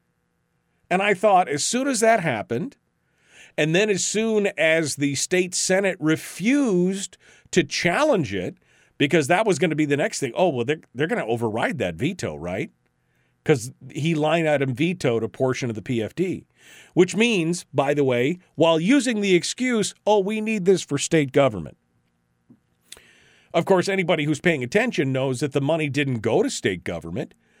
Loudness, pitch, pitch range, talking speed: -22 LUFS, 160 Hz, 135-190 Hz, 175 wpm